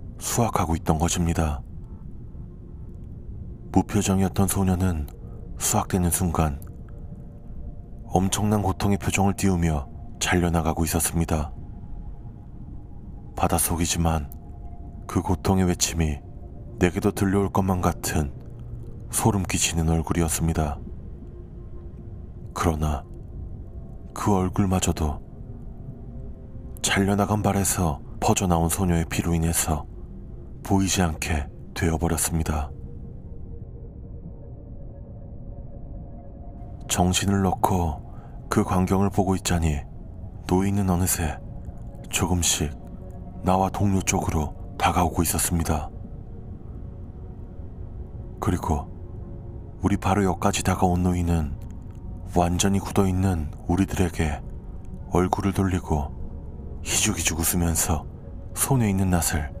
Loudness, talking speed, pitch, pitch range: -24 LUFS, 210 characters per minute, 90 Hz, 85-100 Hz